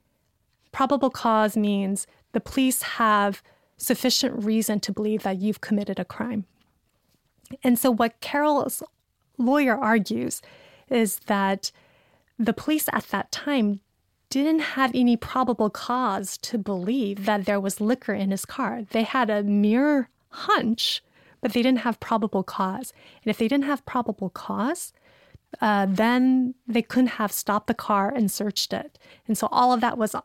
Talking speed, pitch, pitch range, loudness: 155 wpm, 230 Hz, 210-255 Hz, -24 LUFS